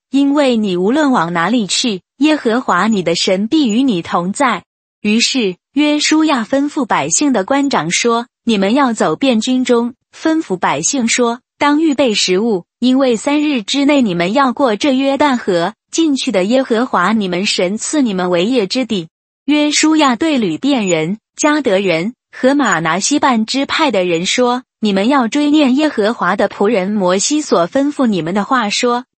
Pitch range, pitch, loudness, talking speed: 200-280 Hz, 245 Hz, -14 LUFS, 250 characters per minute